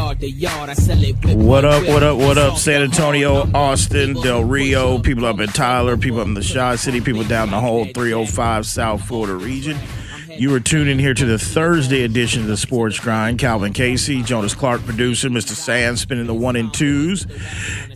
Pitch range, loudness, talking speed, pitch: 110-135 Hz, -17 LUFS, 175 wpm, 120 Hz